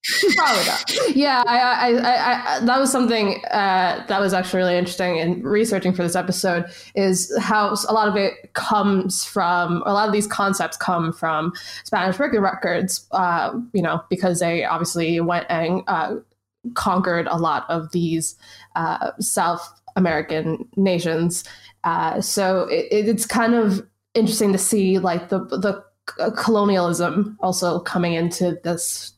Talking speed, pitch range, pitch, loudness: 150 wpm, 175-215 Hz, 190 Hz, -20 LUFS